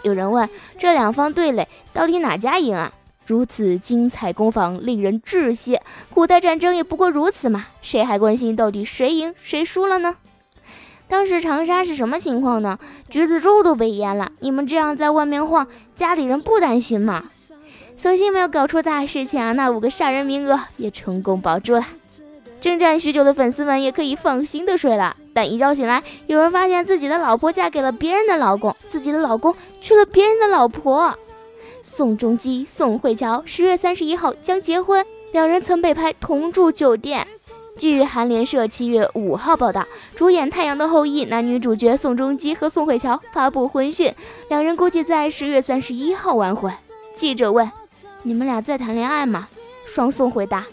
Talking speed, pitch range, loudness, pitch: 280 characters per minute, 240-345 Hz, -18 LUFS, 290 Hz